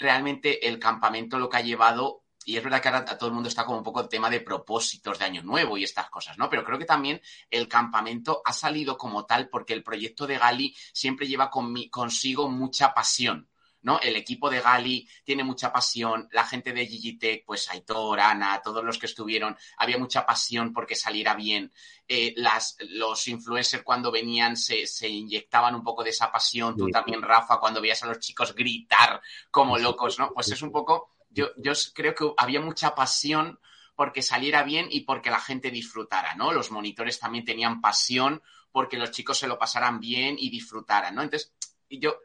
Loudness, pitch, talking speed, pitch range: -26 LUFS, 120 Hz, 195 wpm, 115-135 Hz